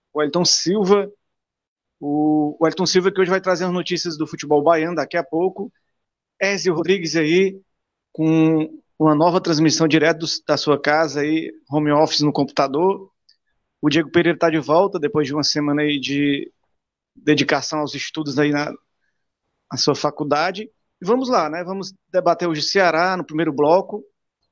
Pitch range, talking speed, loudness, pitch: 150-185 Hz, 165 wpm, -19 LUFS, 160 Hz